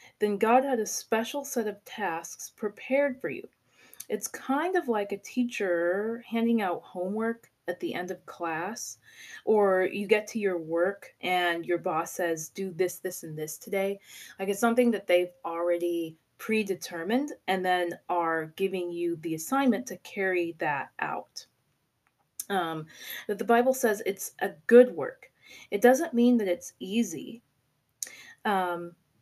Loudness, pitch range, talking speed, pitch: -29 LUFS, 175-230 Hz, 155 wpm, 195 Hz